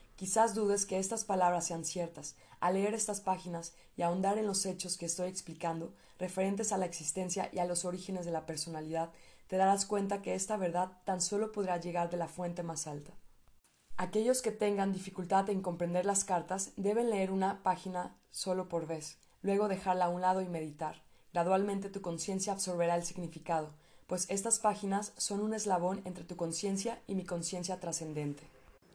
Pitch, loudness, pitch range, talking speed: 185 Hz, -35 LUFS, 170-195 Hz, 180 wpm